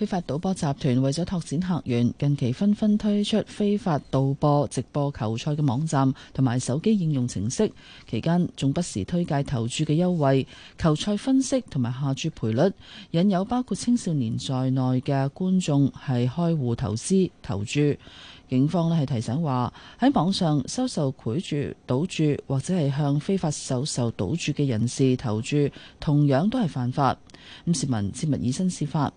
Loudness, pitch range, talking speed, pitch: -25 LUFS, 130-175 Hz, 255 characters per minute, 145 Hz